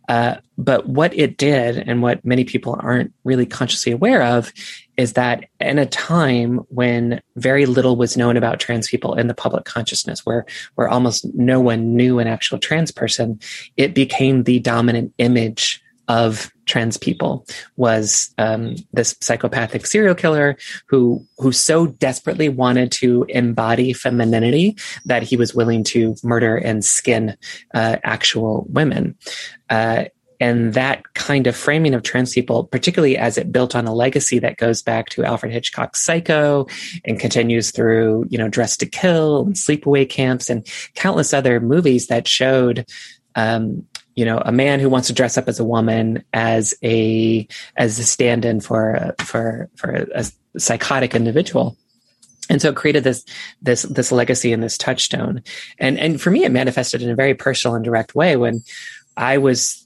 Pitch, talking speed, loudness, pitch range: 120 Hz, 165 wpm, -17 LUFS, 115-130 Hz